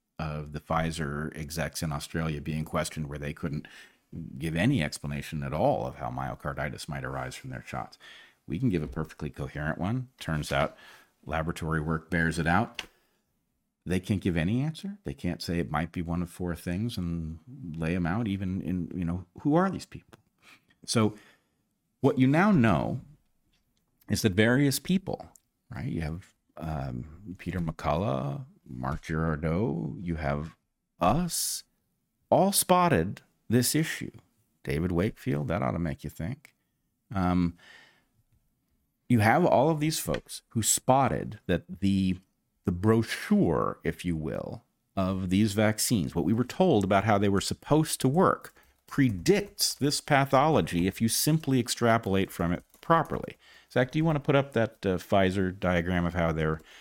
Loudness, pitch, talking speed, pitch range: -28 LUFS, 90 Hz, 160 wpm, 80-125 Hz